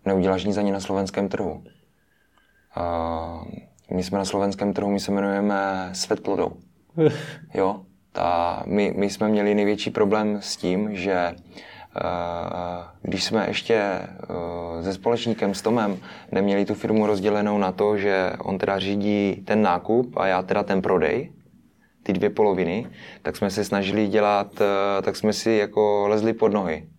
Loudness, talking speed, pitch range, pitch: -23 LUFS, 155 wpm, 95-105 Hz, 100 Hz